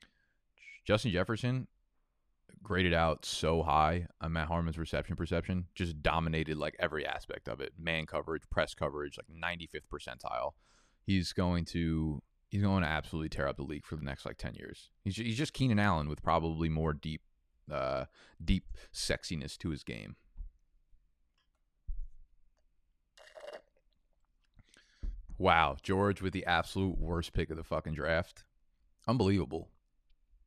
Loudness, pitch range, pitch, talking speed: -34 LUFS, 75-90 Hz, 80 Hz, 135 wpm